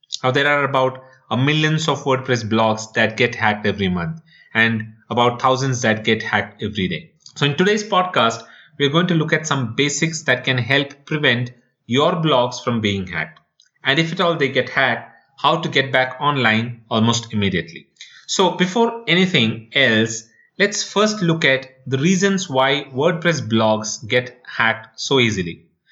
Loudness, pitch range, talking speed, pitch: -18 LUFS, 115-155 Hz, 170 wpm, 130 Hz